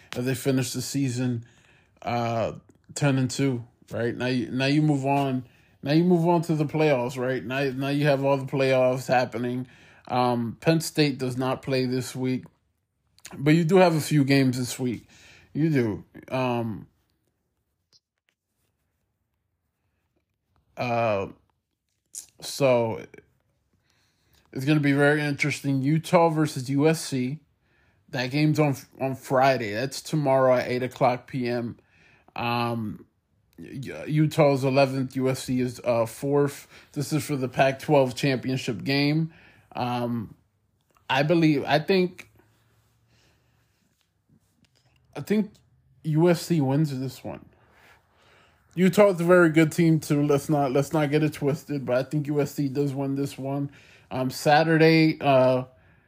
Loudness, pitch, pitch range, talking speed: -24 LUFS, 135 Hz, 125-150 Hz, 135 wpm